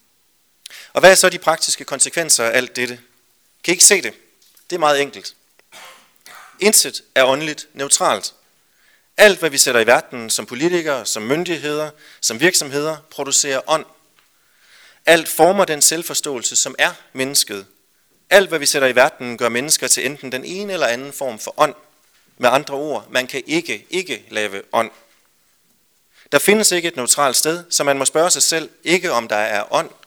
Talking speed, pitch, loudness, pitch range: 175 wpm, 150 Hz, -16 LUFS, 130-170 Hz